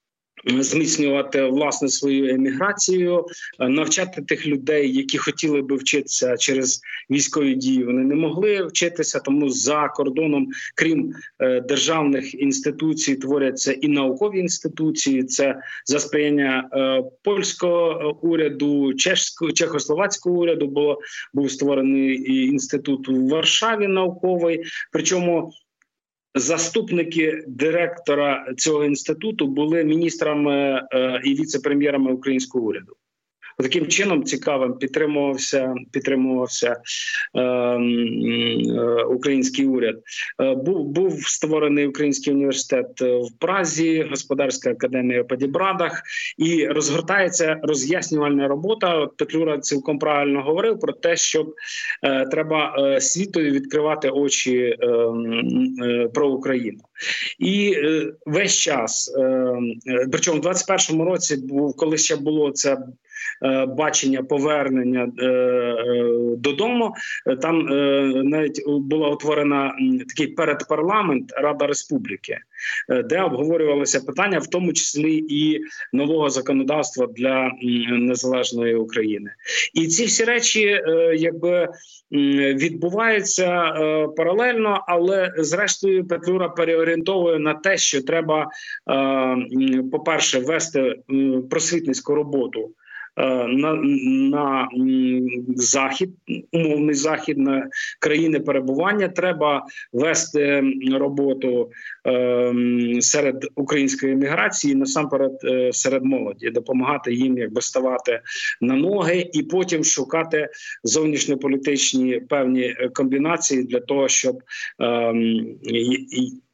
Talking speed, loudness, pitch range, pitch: 95 wpm, -20 LUFS, 135-165 Hz, 145 Hz